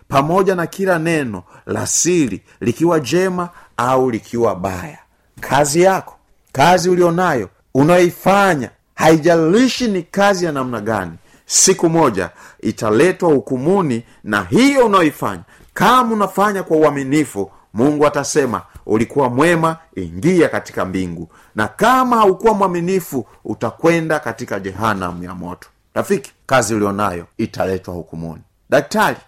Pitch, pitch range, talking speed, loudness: 150 Hz, 110-180 Hz, 115 wpm, -16 LUFS